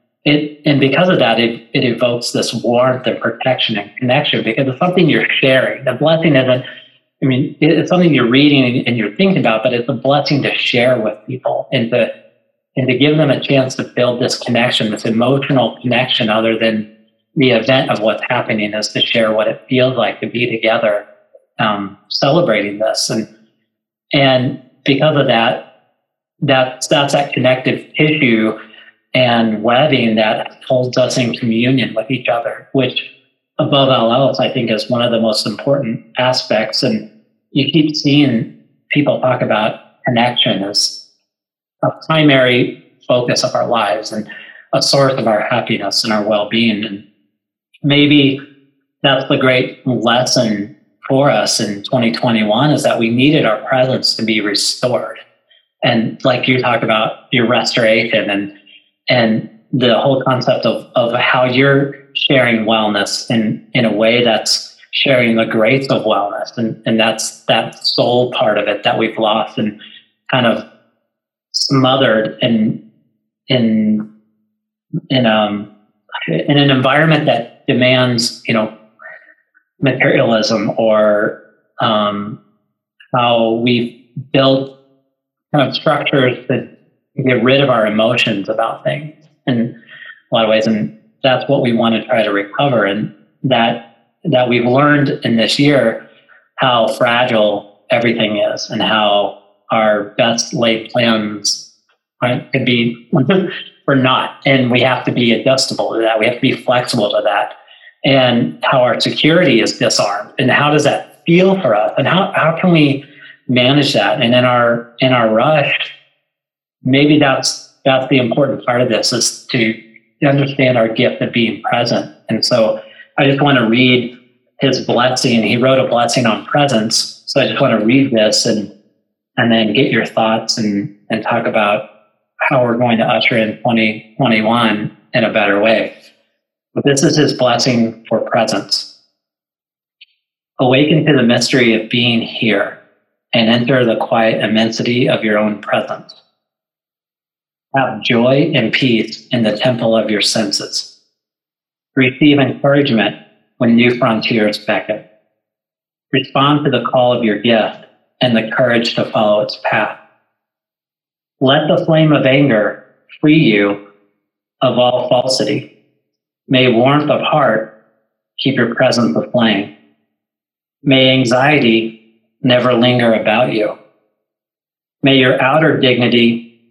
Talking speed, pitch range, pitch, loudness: 150 wpm, 110-135 Hz, 120 Hz, -13 LUFS